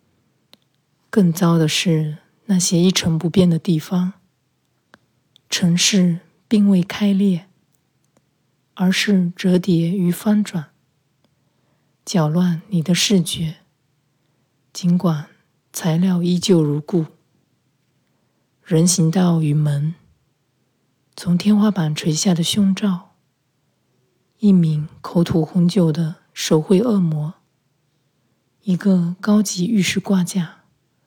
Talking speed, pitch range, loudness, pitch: 140 characters per minute, 155-185 Hz, -18 LUFS, 175 Hz